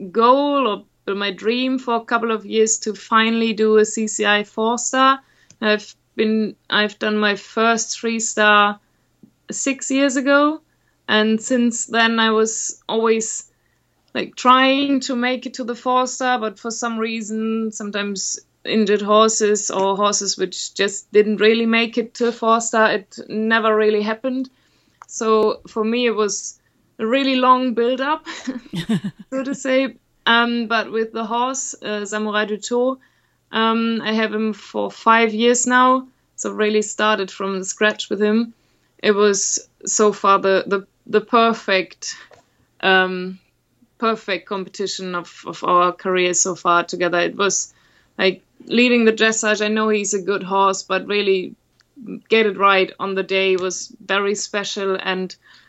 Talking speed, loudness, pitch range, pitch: 155 wpm, -18 LUFS, 200-235 Hz, 220 Hz